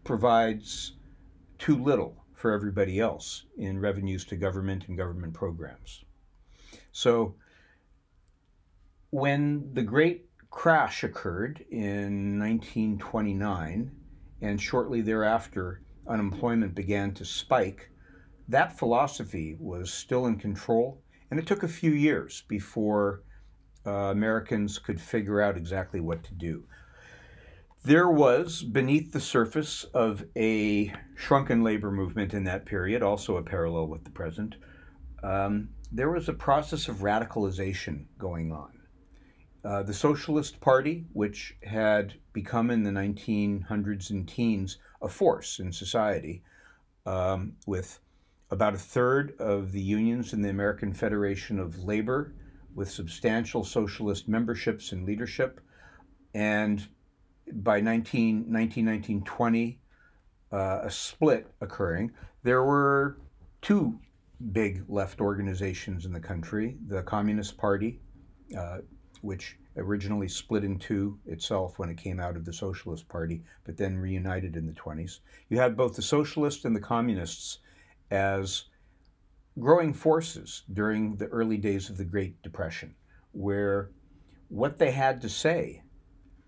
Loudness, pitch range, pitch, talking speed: -29 LUFS, 95-115 Hz, 100 Hz, 125 wpm